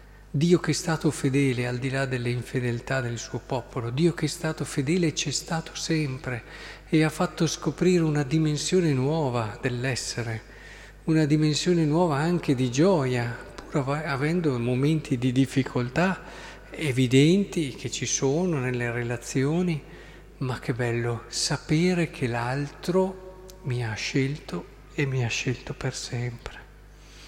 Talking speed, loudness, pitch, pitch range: 135 wpm, -26 LUFS, 145 Hz, 125-160 Hz